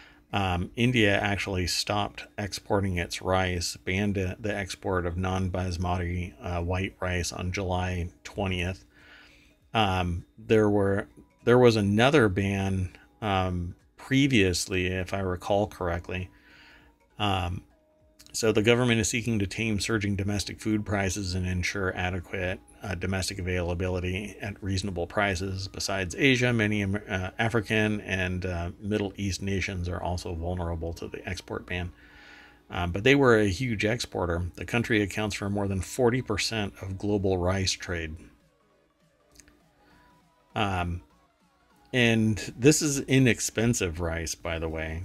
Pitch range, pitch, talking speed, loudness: 90-105 Hz, 95 Hz, 130 wpm, -27 LUFS